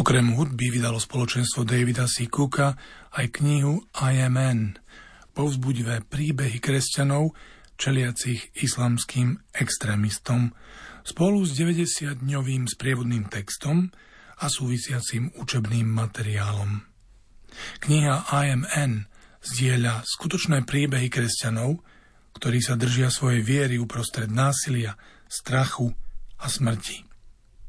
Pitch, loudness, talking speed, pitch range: 125 Hz, -25 LUFS, 95 wpm, 115-140 Hz